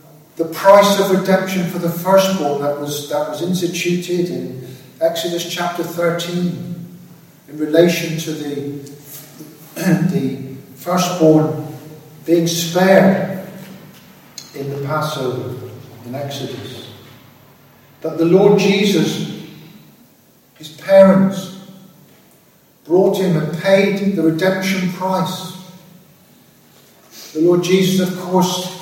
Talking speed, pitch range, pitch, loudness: 100 wpm, 150-185 Hz, 170 Hz, -16 LUFS